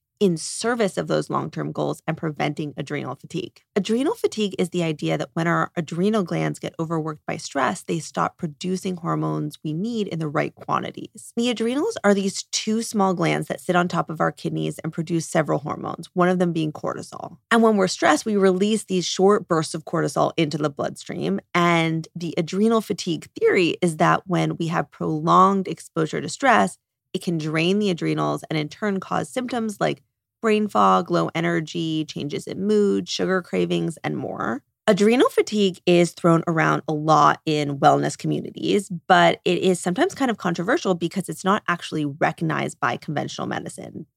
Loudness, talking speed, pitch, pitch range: -22 LUFS, 180 wpm, 175 Hz, 160-200 Hz